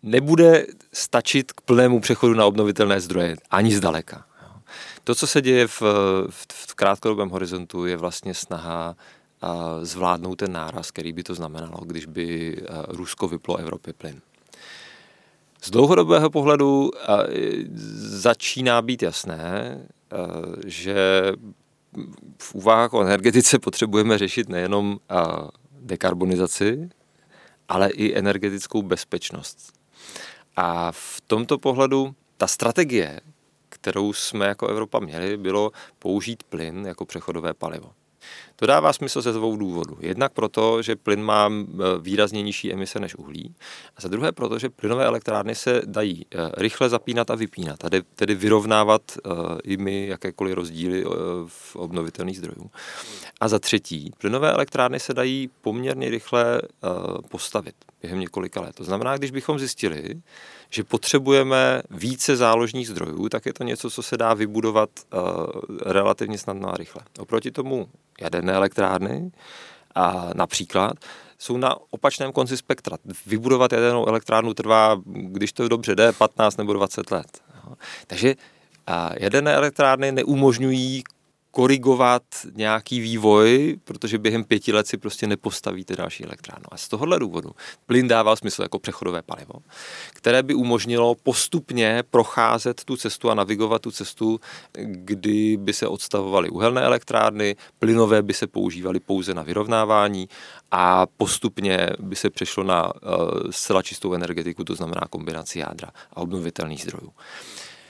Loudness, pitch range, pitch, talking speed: -22 LUFS, 95-120 Hz, 105 Hz, 130 wpm